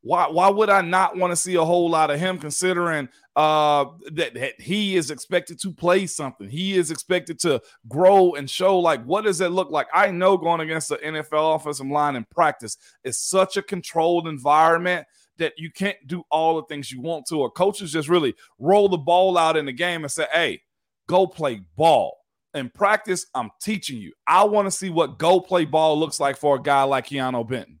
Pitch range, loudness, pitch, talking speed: 150-185 Hz, -21 LUFS, 165 Hz, 215 wpm